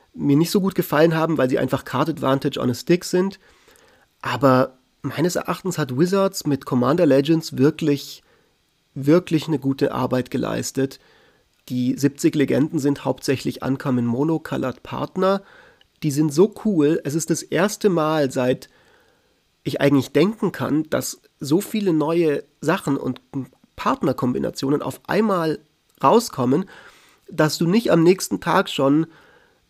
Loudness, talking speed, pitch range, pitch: -21 LUFS, 140 wpm, 135-180 Hz, 155 Hz